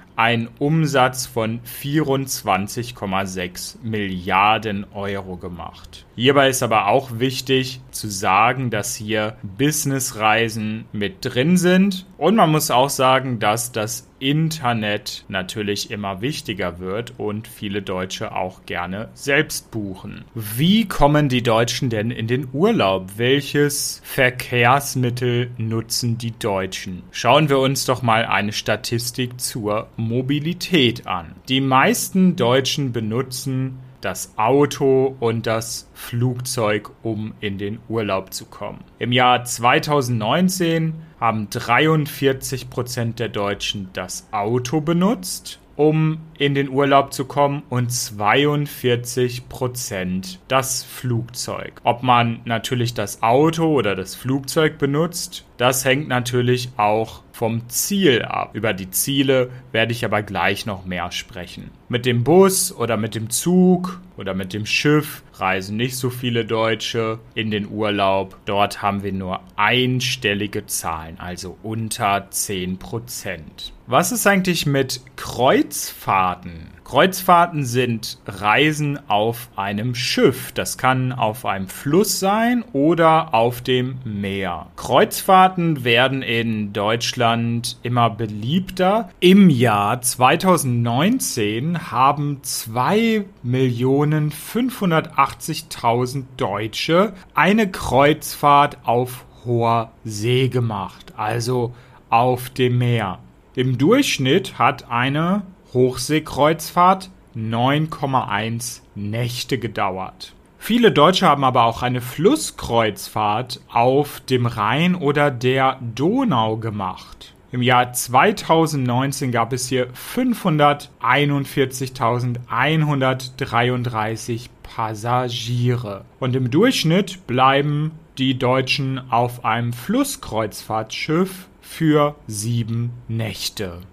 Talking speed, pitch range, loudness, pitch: 105 wpm, 110-145 Hz, -19 LUFS, 125 Hz